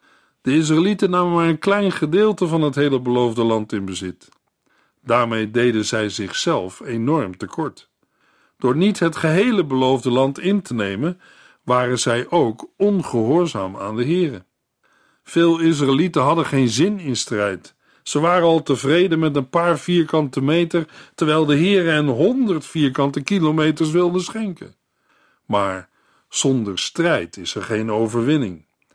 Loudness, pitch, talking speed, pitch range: -19 LUFS, 150 Hz, 140 wpm, 120-170 Hz